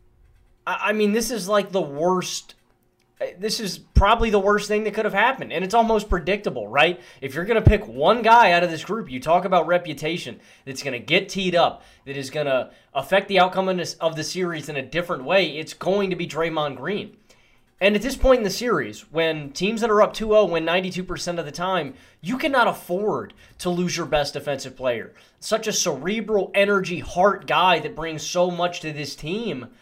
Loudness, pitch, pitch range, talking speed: -22 LUFS, 180 Hz, 160-205 Hz, 215 wpm